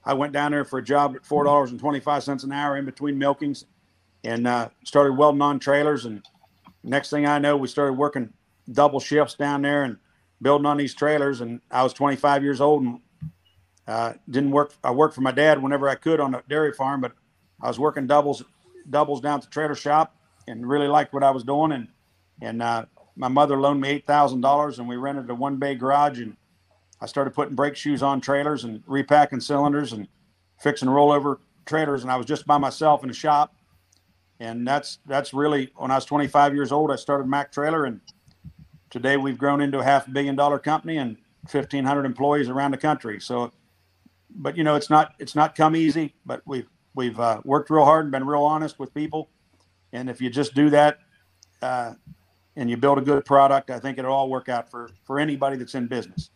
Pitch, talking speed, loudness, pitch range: 140 Hz, 210 wpm, -22 LUFS, 125-145 Hz